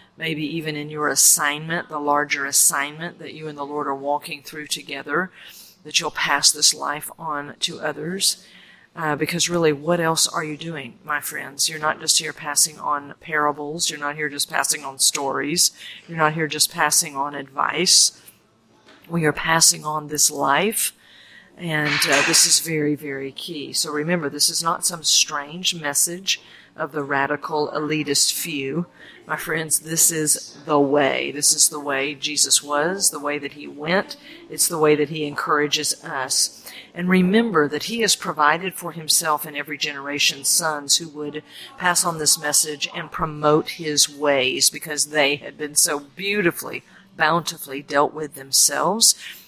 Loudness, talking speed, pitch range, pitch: -20 LUFS, 165 wpm, 145-165 Hz, 150 Hz